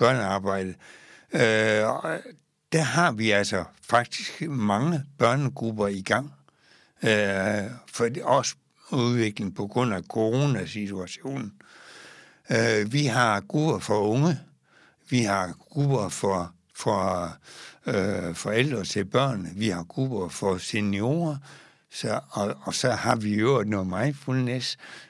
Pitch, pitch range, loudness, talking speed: 115 Hz, 100-135 Hz, -26 LUFS, 120 wpm